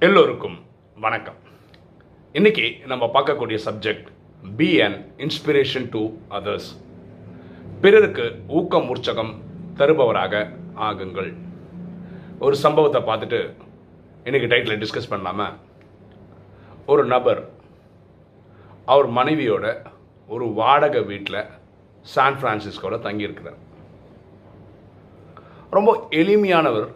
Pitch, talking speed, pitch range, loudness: 115 Hz, 80 wpm, 100-165 Hz, -20 LUFS